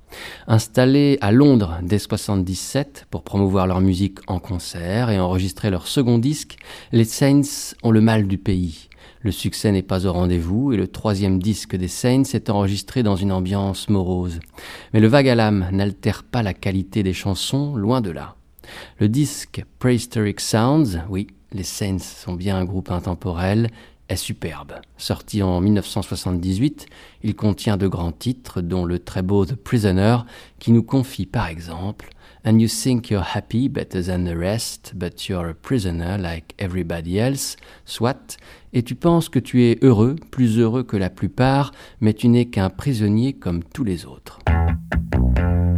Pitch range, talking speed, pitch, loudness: 90-120 Hz, 165 wpm, 100 Hz, -20 LUFS